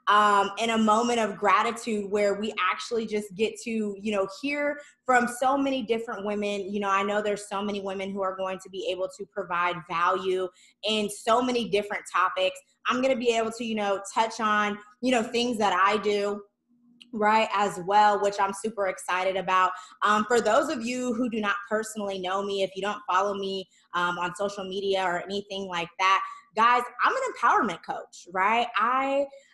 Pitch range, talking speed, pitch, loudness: 195-230 Hz, 195 wpm, 205 Hz, -26 LUFS